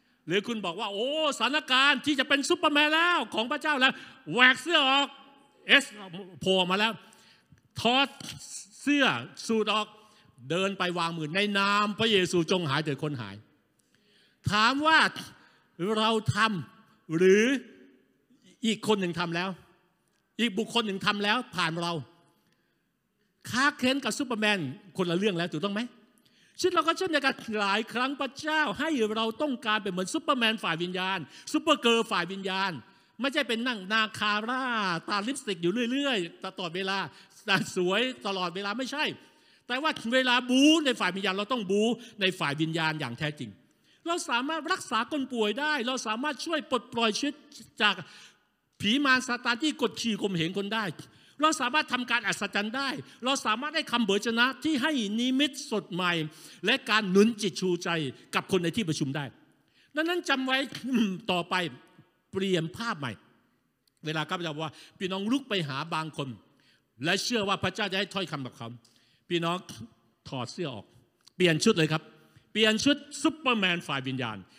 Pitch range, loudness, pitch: 180-255 Hz, -27 LUFS, 210 Hz